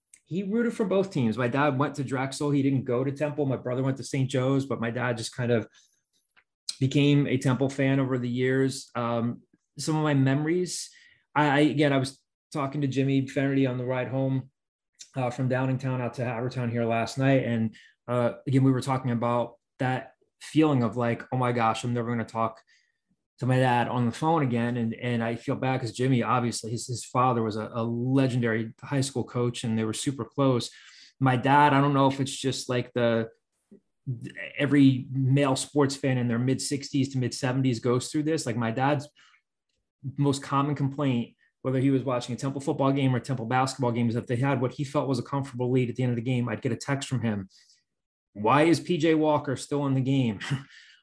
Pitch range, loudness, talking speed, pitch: 120-140 Hz, -27 LUFS, 215 wpm, 130 Hz